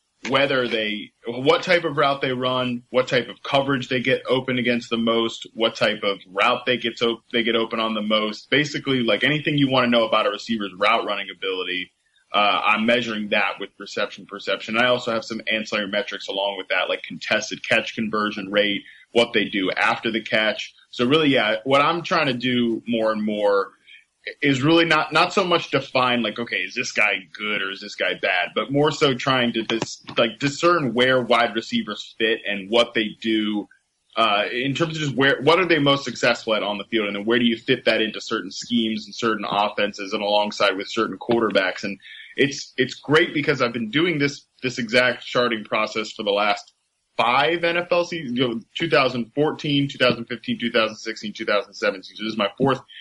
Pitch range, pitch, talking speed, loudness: 110-135 Hz, 120 Hz, 205 wpm, -21 LUFS